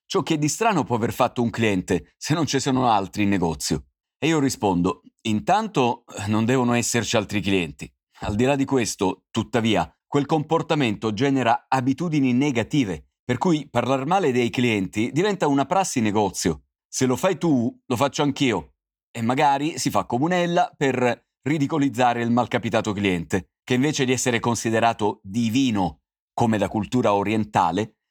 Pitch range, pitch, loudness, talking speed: 105-140 Hz, 120 Hz, -22 LUFS, 155 wpm